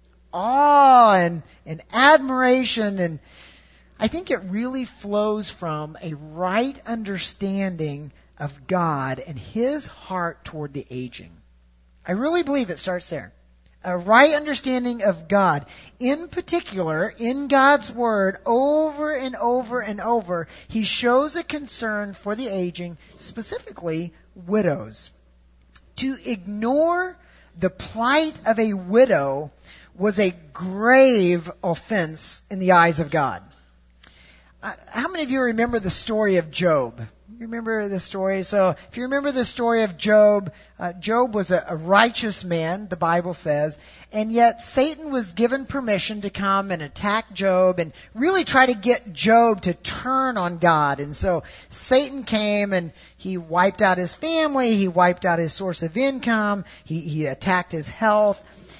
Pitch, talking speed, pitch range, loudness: 200 Hz, 145 wpm, 170-245 Hz, -21 LUFS